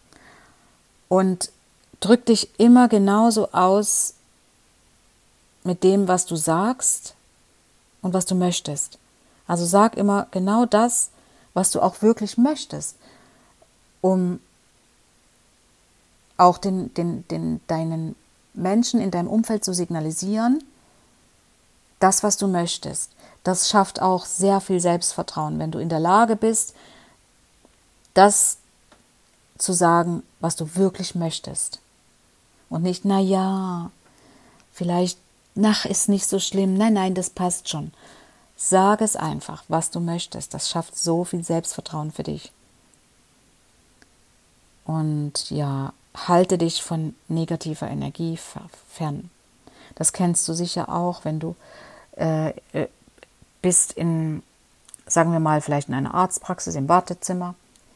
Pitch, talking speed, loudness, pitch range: 180 Hz, 120 wpm, -21 LUFS, 165-195 Hz